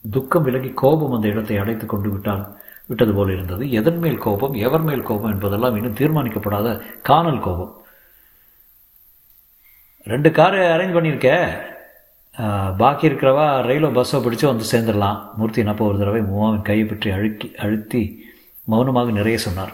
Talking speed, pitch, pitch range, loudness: 130 wpm, 115 Hz, 105-130 Hz, -19 LUFS